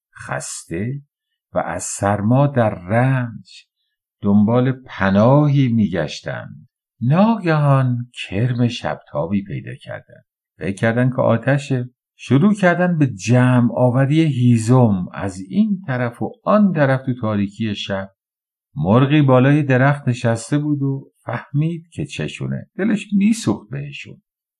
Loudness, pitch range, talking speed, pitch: -18 LUFS, 110-145 Hz, 105 wpm, 125 Hz